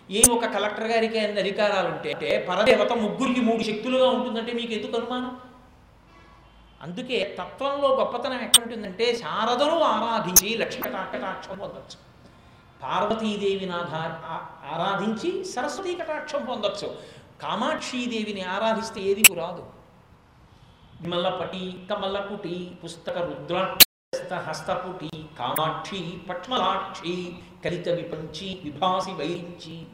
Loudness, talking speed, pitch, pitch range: -24 LUFS, 80 wpm, 200 Hz, 175-235 Hz